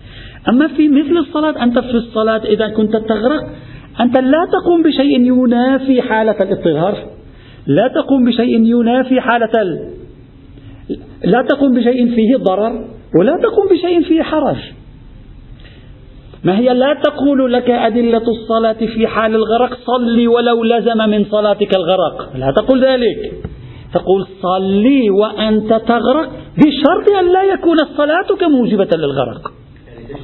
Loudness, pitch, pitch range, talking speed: -13 LUFS, 235 Hz, 210-275 Hz, 125 wpm